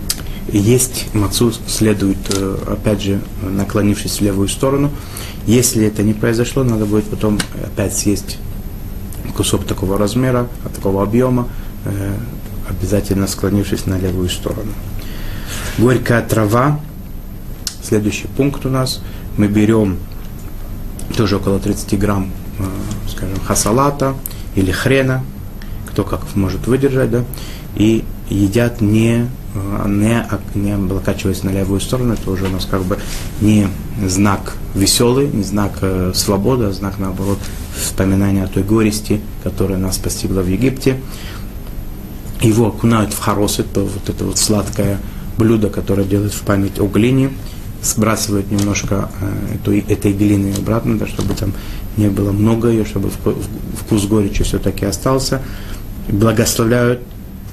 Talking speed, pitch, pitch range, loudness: 125 wpm, 100 Hz, 100-110 Hz, -16 LUFS